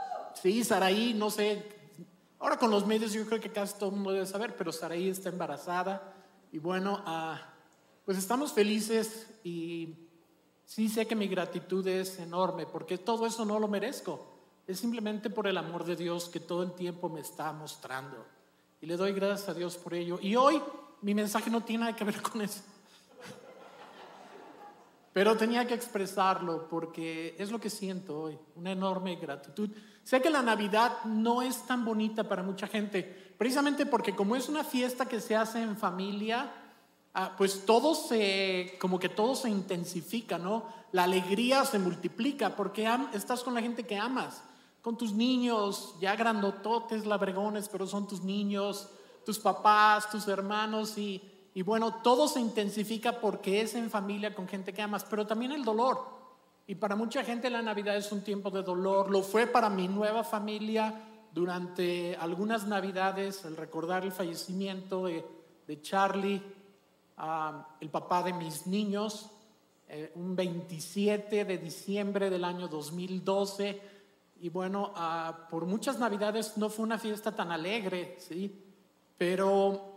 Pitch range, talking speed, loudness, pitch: 180-220 Hz, 165 wpm, -32 LUFS, 200 Hz